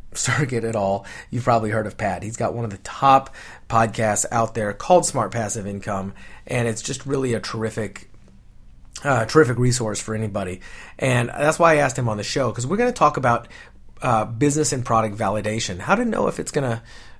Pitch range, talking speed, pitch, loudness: 110-135 Hz, 205 wpm, 115 Hz, -21 LUFS